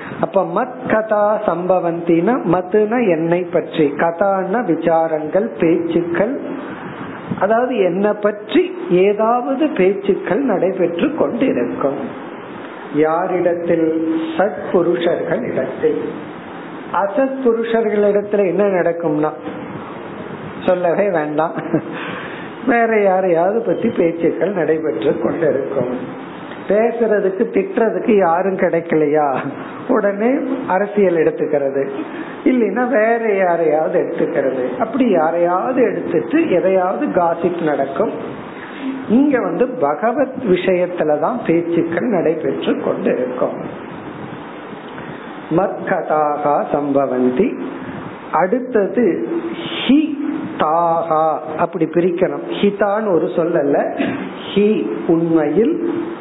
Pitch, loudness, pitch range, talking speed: 185 Hz, -17 LUFS, 165-225 Hz, 75 wpm